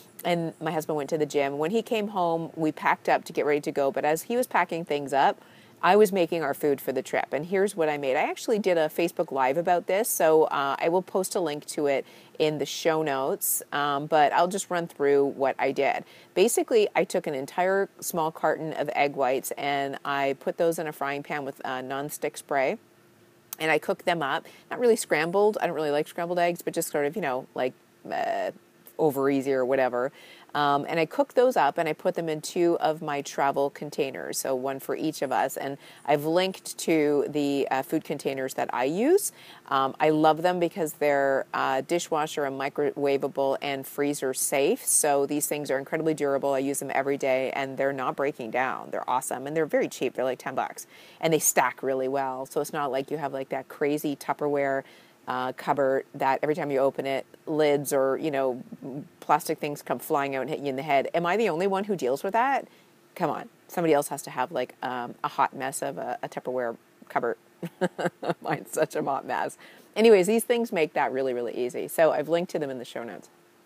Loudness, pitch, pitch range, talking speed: -26 LUFS, 150 Hz, 135-170 Hz, 225 wpm